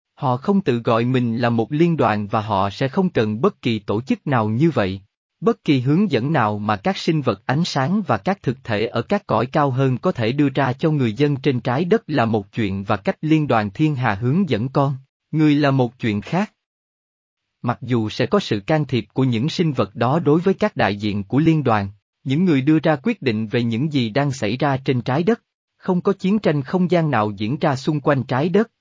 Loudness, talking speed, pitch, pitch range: -20 LUFS, 240 wpm, 140 Hz, 115-165 Hz